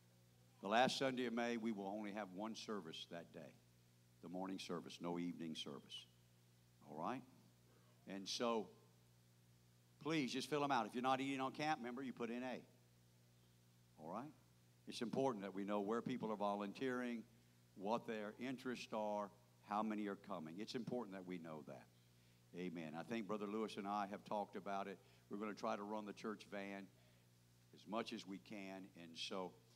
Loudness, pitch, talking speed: -46 LUFS, 95 Hz, 185 wpm